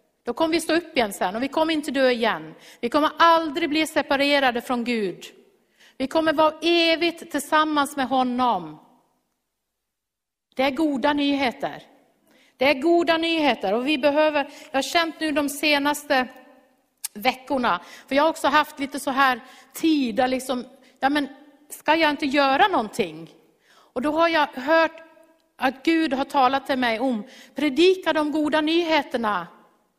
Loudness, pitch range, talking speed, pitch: -22 LUFS, 255-310 Hz, 155 wpm, 280 Hz